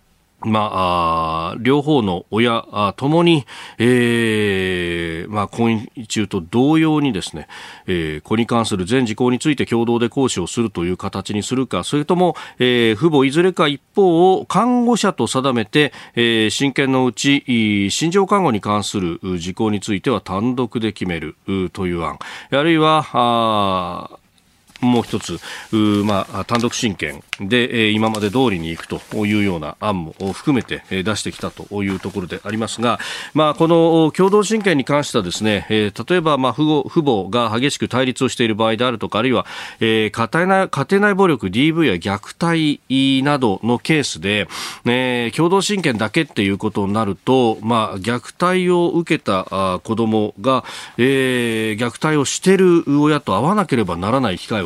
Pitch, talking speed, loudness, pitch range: 120 Hz, 300 characters per minute, -17 LUFS, 105-145 Hz